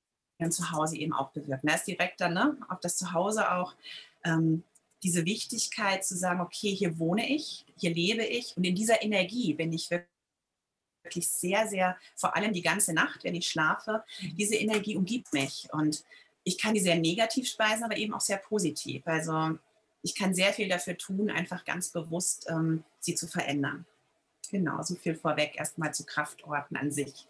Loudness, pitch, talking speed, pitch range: -30 LUFS, 180 Hz, 180 wpm, 160-210 Hz